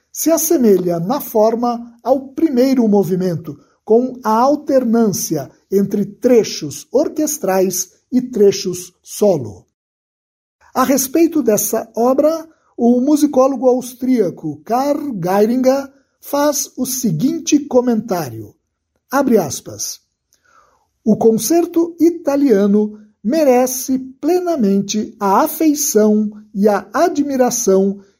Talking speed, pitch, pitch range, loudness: 85 wpm, 240 Hz, 200-275 Hz, -16 LUFS